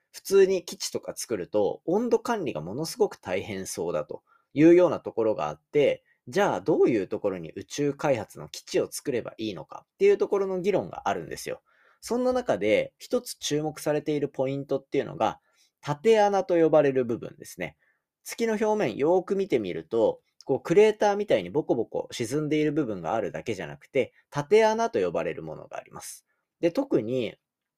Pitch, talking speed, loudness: 205 Hz, 380 characters per minute, -26 LUFS